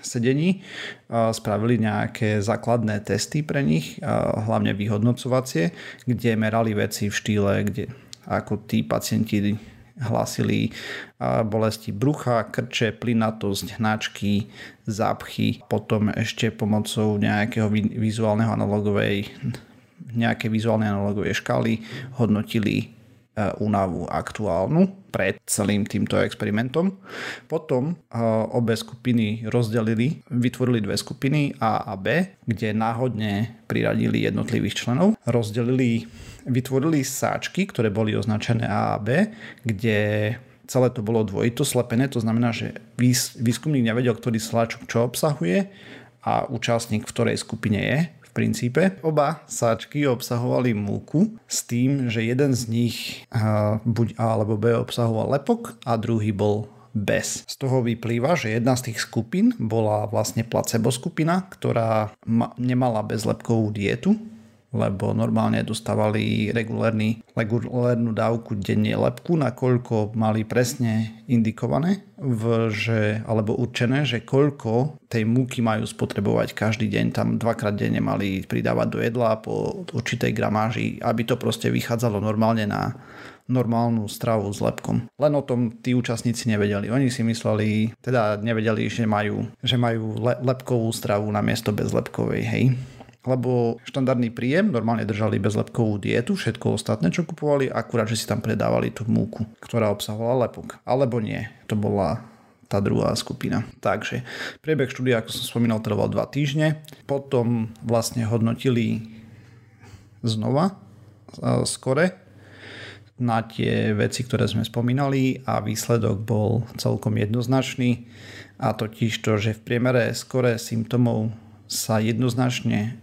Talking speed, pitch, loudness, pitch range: 125 wpm, 115 Hz, -24 LUFS, 110-125 Hz